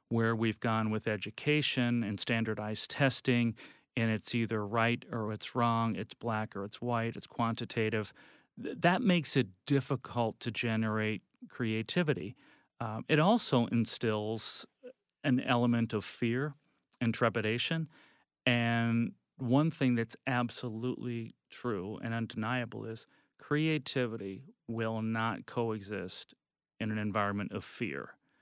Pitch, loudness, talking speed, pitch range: 115 Hz, -33 LUFS, 120 wpm, 110-125 Hz